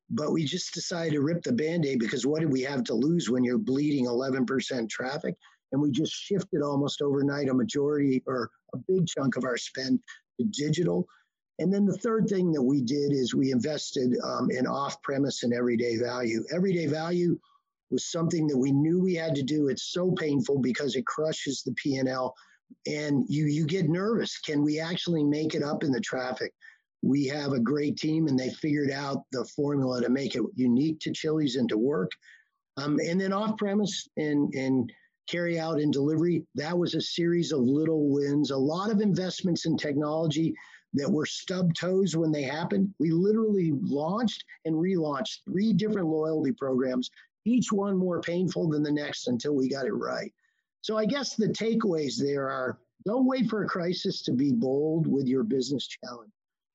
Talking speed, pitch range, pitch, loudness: 190 wpm, 140-185 Hz, 155 Hz, -28 LUFS